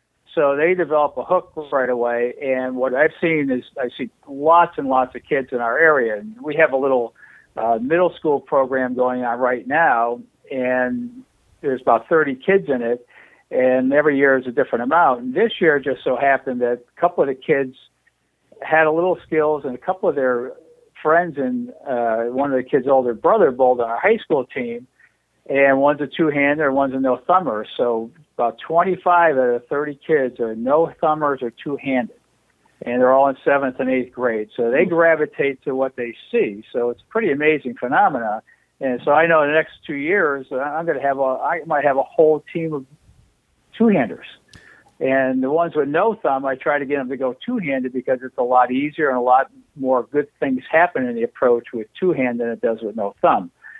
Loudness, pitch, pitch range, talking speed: -19 LUFS, 135 Hz, 125-155 Hz, 205 wpm